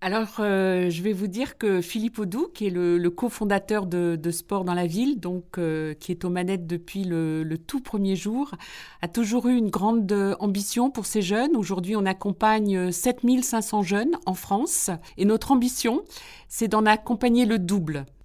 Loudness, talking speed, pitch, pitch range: -25 LUFS, 185 wpm, 205 Hz, 180-235 Hz